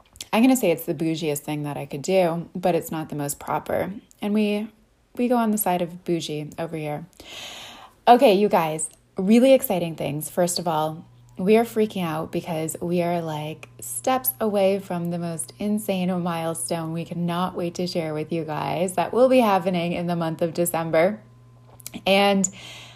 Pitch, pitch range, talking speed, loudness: 175 Hz, 160-195 Hz, 185 wpm, -23 LUFS